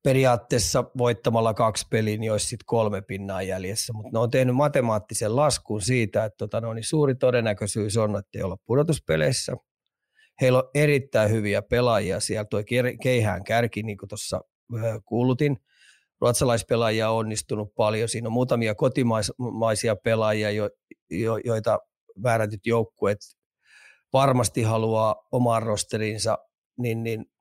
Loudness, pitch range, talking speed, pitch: -24 LUFS, 105-125 Hz, 115 wpm, 115 Hz